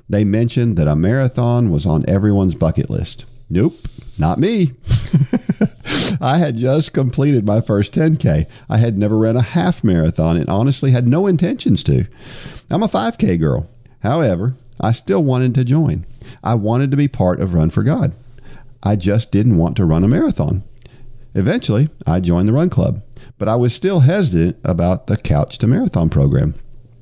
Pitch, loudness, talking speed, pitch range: 120 Hz, -16 LUFS, 170 wpm, 100-135 Hz